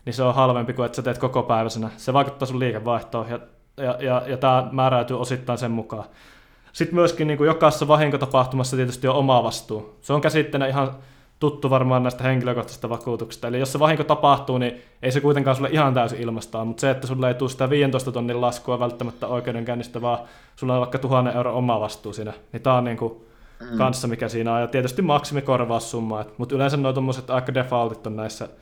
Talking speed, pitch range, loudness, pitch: 195 wpm, 120-135 Hz, -22 LUFS, 125 Hz